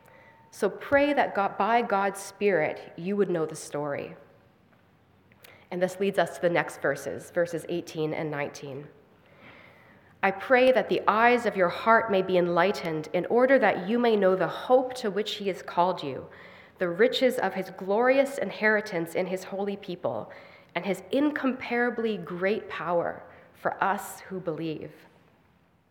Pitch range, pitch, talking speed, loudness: 170-215 Hz, 190 Hz, 160 wpm, -27 LUFS